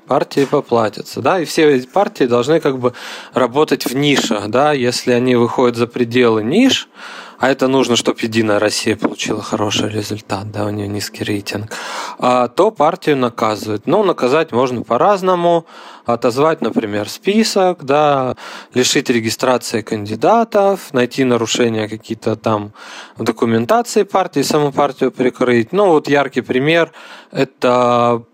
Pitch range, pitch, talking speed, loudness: 115-150 Hz, 125 Hz, 135 wpm, -15 LUFS